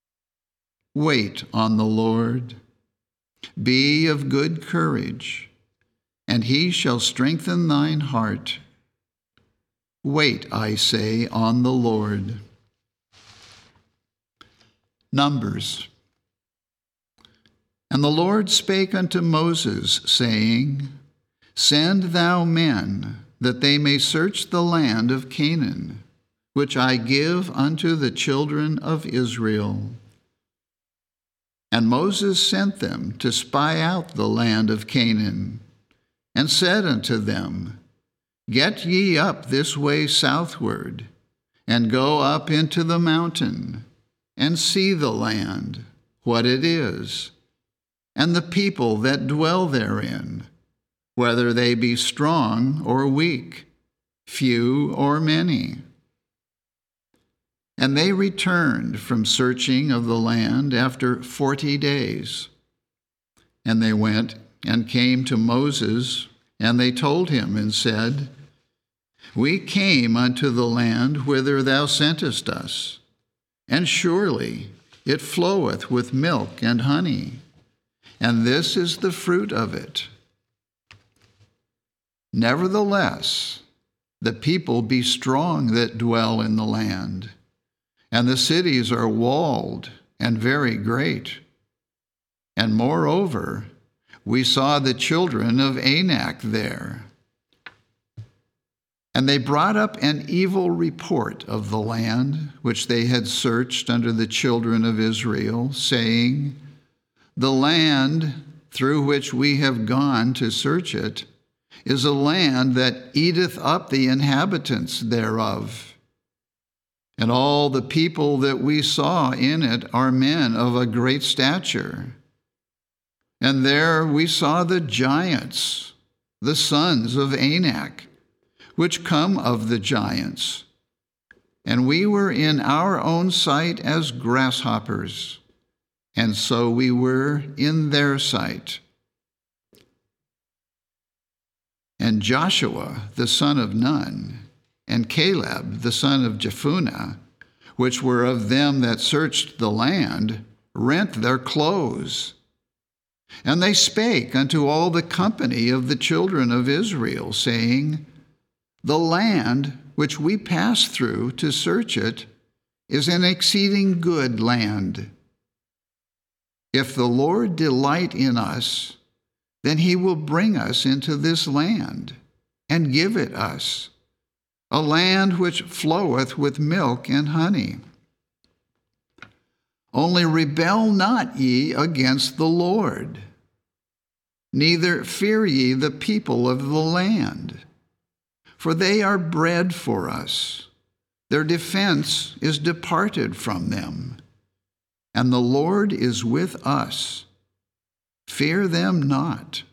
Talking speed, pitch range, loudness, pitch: 110 wpm, 115-155 Hz, -21 LUFS, 130 Hz